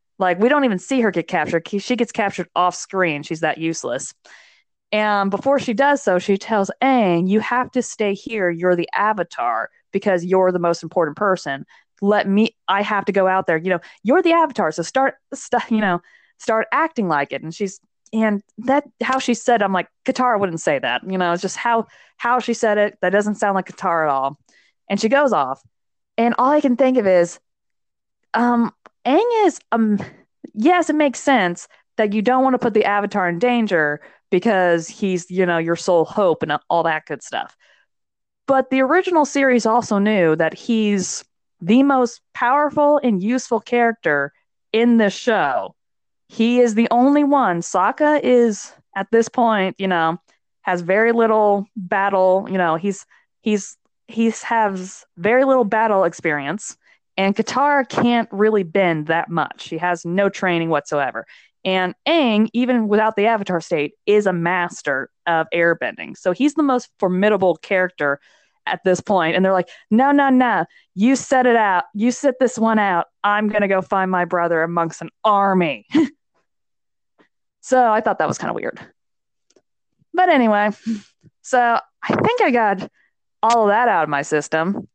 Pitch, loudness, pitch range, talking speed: 210 Hz, -18 LUFS, 180-245 Hz, 180 wpm